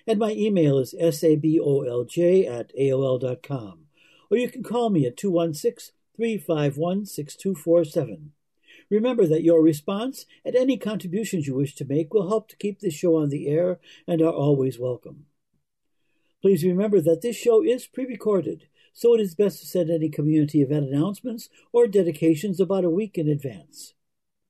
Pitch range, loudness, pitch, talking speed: 150-210 Hz, -23 LUFS, 170 Hz, 150 wpm